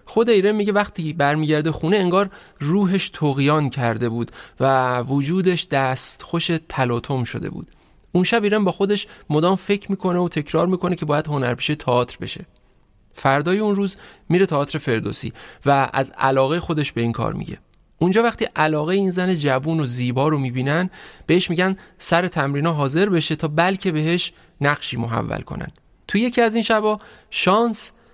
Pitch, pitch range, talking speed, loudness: 165 Hz, 140-190 Hz, 165 wpm, -20 LUFS